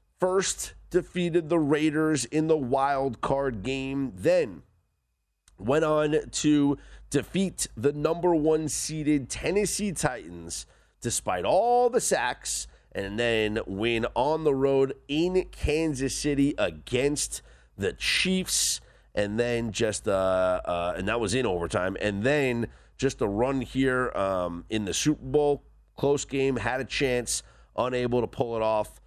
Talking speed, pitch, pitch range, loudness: 140 wpm, 135 Hz, 105-155 Hz, -27 LUFS